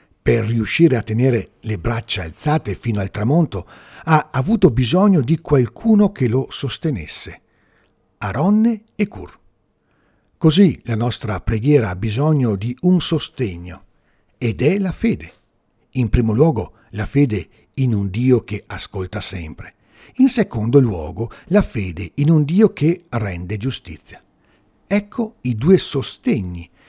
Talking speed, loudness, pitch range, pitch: 135 wpm, -18 LUFS, 105-160 Hz, 120 Hz